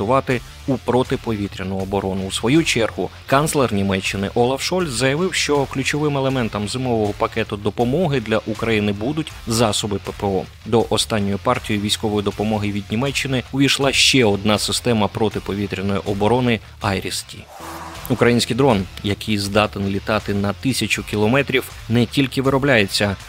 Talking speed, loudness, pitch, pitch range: 125 wpm, -19 LUFS, 110 Hz, 100-130 Hz